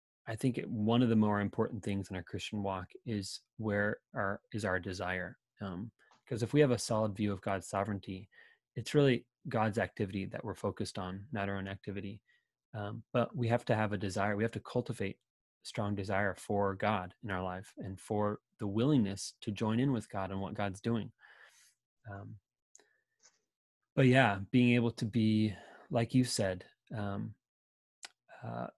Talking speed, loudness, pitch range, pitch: 180 wpm, -34 LUFS, 100-115 Hz, 105 Hz